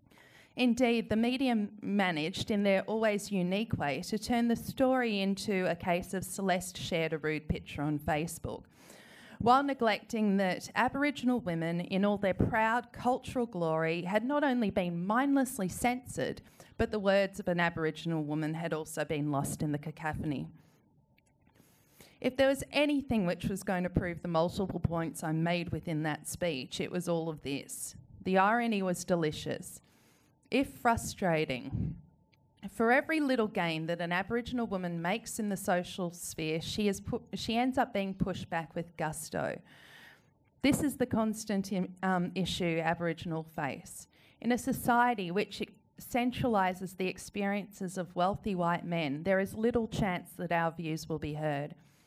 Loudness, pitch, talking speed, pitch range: -32 LUFS, 190 Hz, 160 wpm, 165-225 Hz